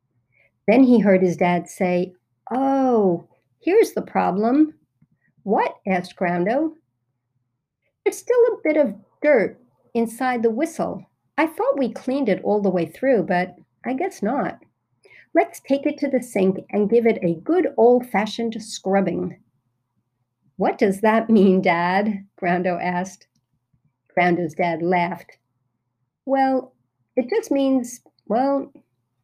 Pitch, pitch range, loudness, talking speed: 195 Hz, 170-260 Hz, -21 LUFS, 130 wpm